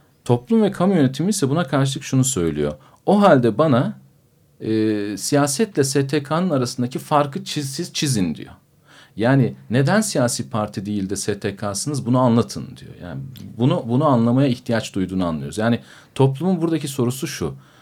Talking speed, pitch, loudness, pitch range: 140 wpm, 130 Hz, -20 LUFS, 110-150 Hz